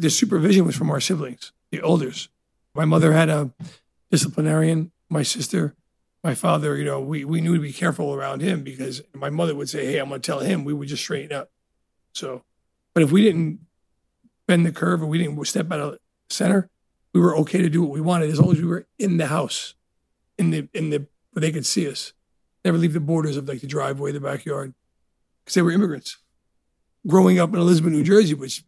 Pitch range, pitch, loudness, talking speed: 145-175 Hz, 160 Hz, -21 LUFS, 220 wpm